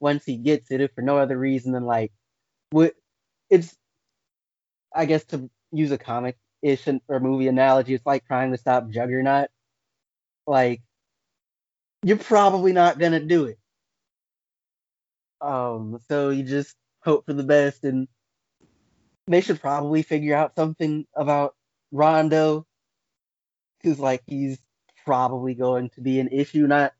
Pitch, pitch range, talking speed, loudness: 140 Hz, 125-150 Hz, 135 wpm, -22 LUFS